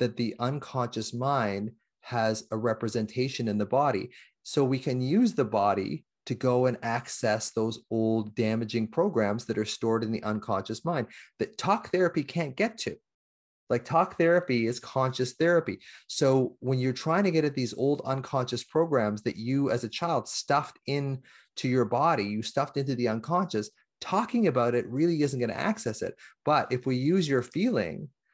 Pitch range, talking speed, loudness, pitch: 110-140 Hz, 175 wpm, -28 LUFS, 125 Hz